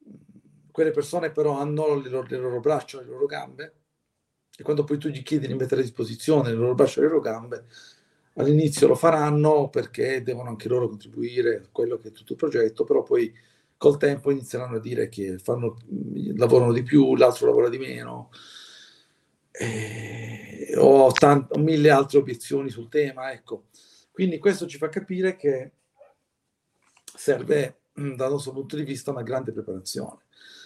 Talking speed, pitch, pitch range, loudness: 160 wpm, 140 Hz, 125-155 Hz, -23 LUFS